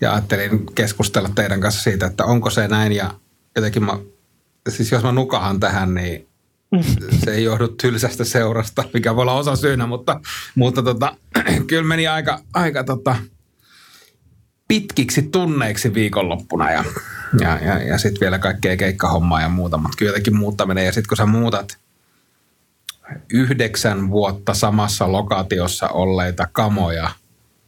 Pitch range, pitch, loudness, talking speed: 100-125 Hz, 110 Hz, -18 LUFS, 140 wpm